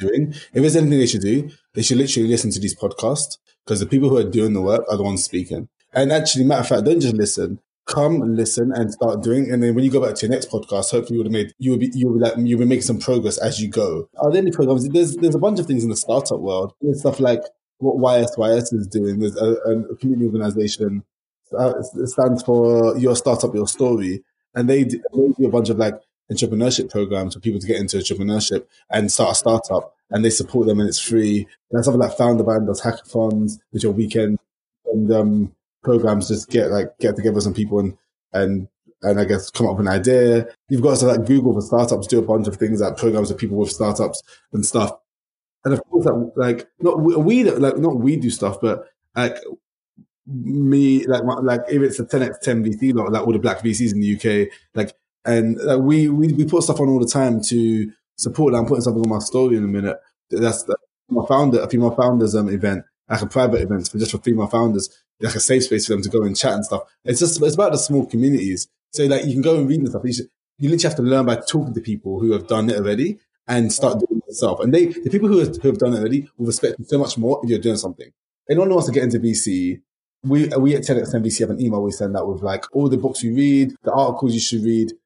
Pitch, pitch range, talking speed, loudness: 115 Hz, 110-135 Hz, 245 wpm, -19 LUFS